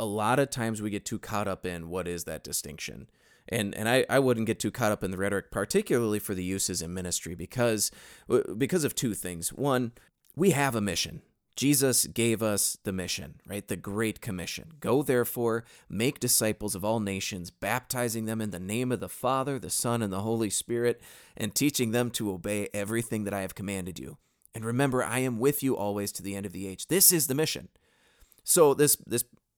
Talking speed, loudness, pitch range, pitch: 210 wpm, -28 LUFS, 100-125 Hz, 110 Hz